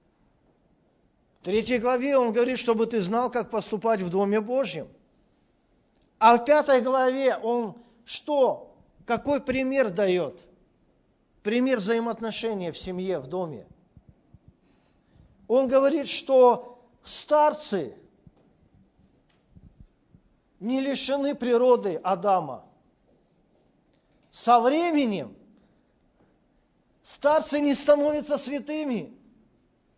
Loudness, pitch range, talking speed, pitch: -24 LUFS, 220-270 Hz, 85 wpm, 245 Hz